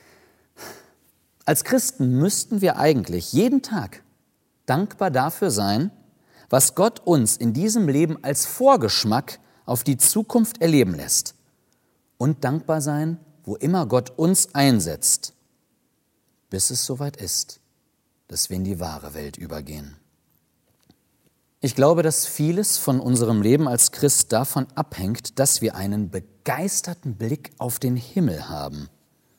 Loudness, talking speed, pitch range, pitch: -21 LUFS, 125 wpm, 100-165 Hz, 135 Hz